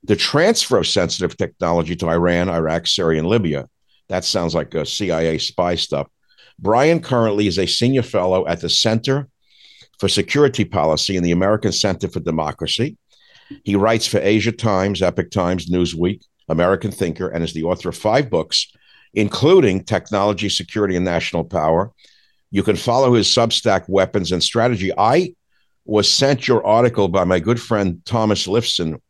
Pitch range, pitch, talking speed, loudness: 85-110 Hz, 100 Hz, 160 wpm, -18 LUFS